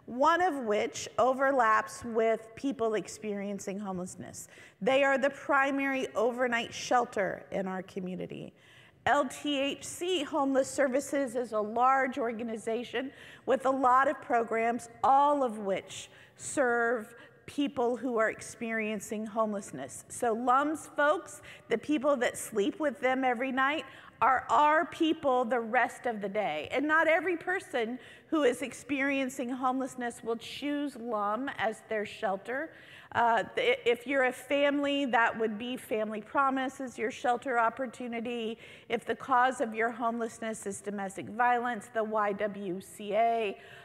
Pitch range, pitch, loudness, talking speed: 225-275 Hz, 245 Hz, -30 LUFS, 130 wpm